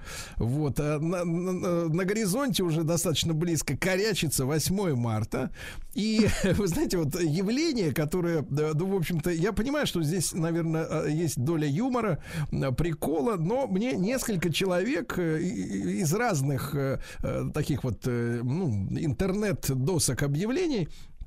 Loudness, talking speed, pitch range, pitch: -28 LUFS, 115 wpm, 145-185 Hz, 165 Hz